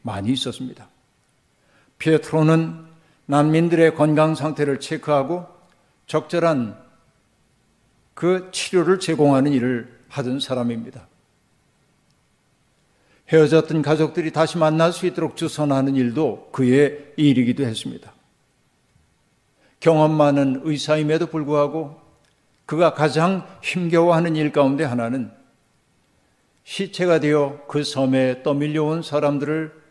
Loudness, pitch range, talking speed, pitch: -20 LUFS, 140-160 Hz, 245 characters per minute, 155 Hz